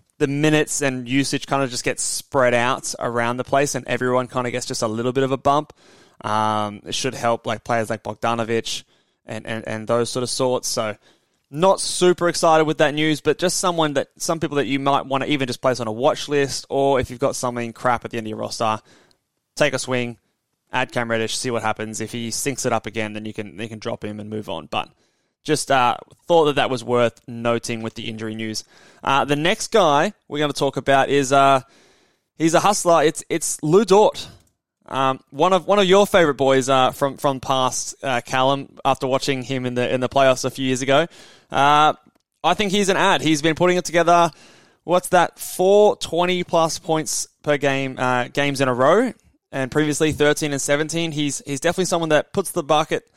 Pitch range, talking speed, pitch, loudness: 120-155 Hz, 220 wpm, 135 Hz, -20 LUFS